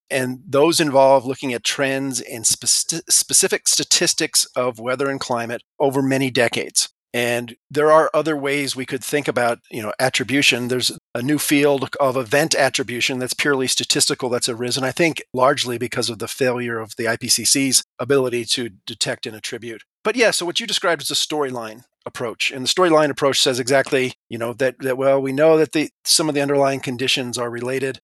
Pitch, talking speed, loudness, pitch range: 135 Hz, 190 wpm, -19 LUFS, 125-145 Hz